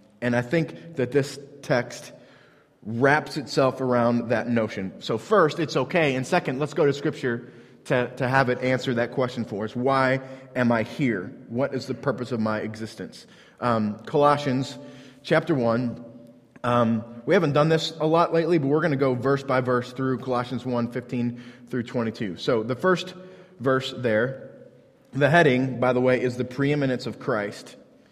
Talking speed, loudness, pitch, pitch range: 175 wpm, -24 LUFS, 130 Hz, 120-140 Hz